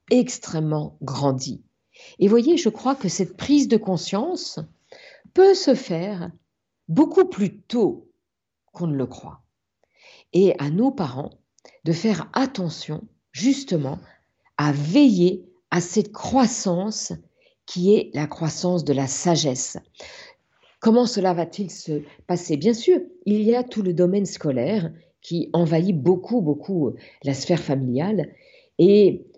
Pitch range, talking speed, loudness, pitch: 165-240 Hz, 130 wpm, -22 LUFS, 190 Hz